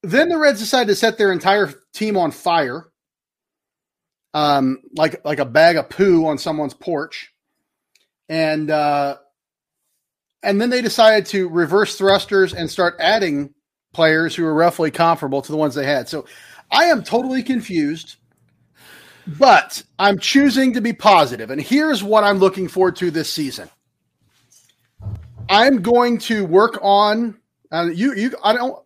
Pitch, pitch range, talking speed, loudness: 185 Hz, 150-220 Hz, 150 wpm, -17 LUFS